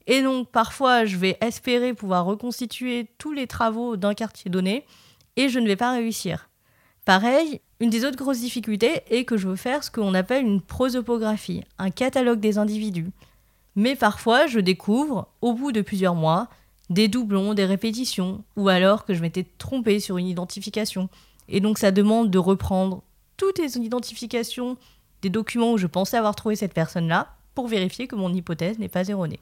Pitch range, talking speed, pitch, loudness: 190-245 Hz, 180 wpm, 215 Hz, -23 LUFS